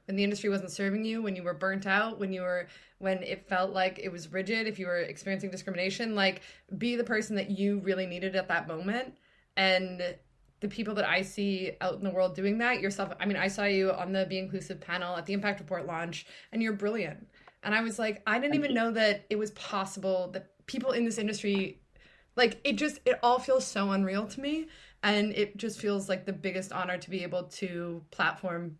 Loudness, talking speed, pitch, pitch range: -31 LUFS, 225 wpm, 195 Hz, 185-215 Hz